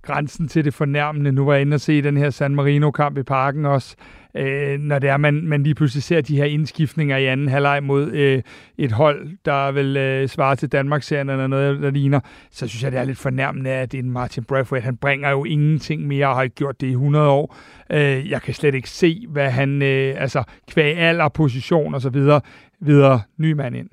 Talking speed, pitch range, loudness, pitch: 230 wpm, 135-150 Hz, -19 LUFS, 140 Hz